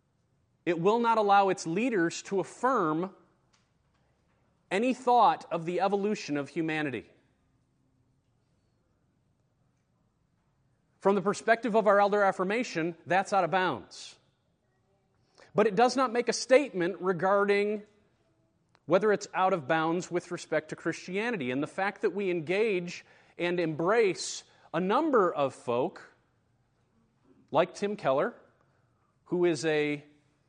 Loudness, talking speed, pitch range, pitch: -28 LUFS, 120 wpm, 155-205 Hz, 180 Hz